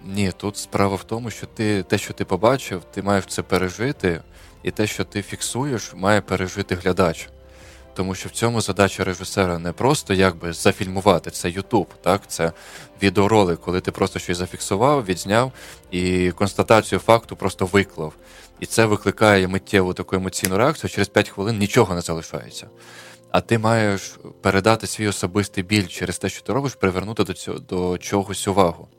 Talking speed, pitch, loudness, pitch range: 165 wpm, 95 Hz, -21 LUFS, 90-105 Hz